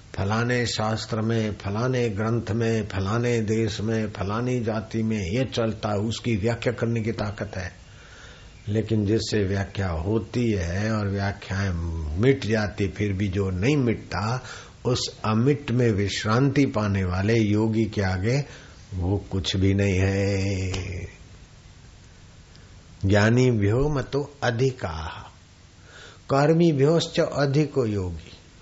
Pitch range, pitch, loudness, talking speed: 95-115 Hz, 105 Hz, -24 LUFS, 115 wpm